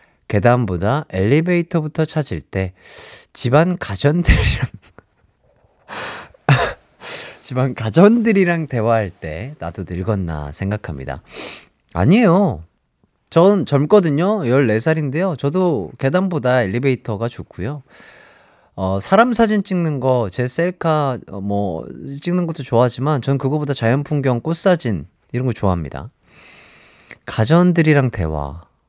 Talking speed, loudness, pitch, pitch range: 245 characters per minute, -18 LUFS, 130 Hz, 100-165 Hz